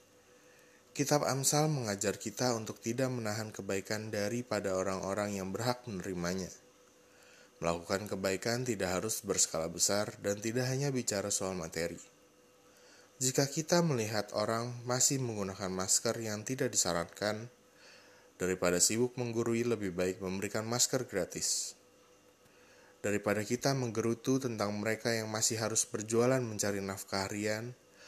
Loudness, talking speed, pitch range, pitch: -33 LUFS, 120 wpm, 95-120 Hz, 110 Hz